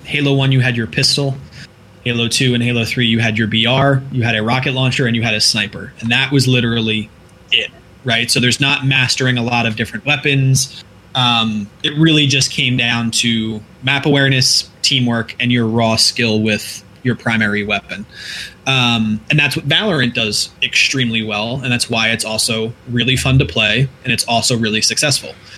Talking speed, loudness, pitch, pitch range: 190 wpm, -14 LUFS, 120 Hz, 110-135 Hz